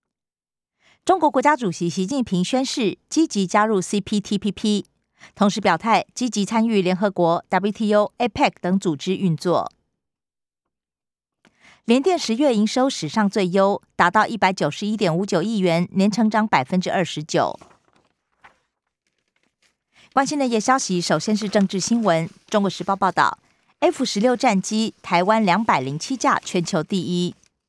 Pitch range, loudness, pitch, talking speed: 180-225 Hz, -20 LUFS, 205 Hz, 235 characters per minute